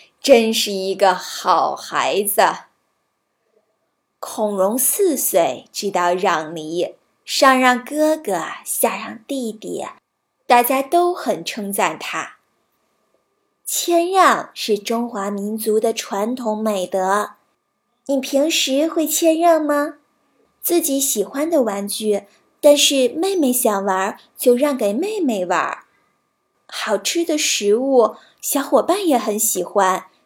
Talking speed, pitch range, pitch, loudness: 160 characters per minute, 205-295 Hz, 245 Hz, -18 LUFS